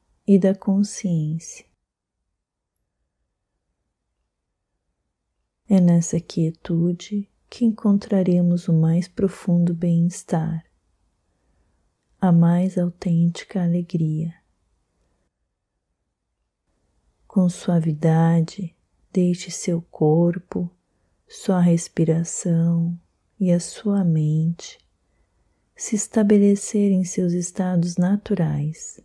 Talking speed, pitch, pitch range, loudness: 70 wpm, 175 Hz, 165-190 Hz, -21 LUFS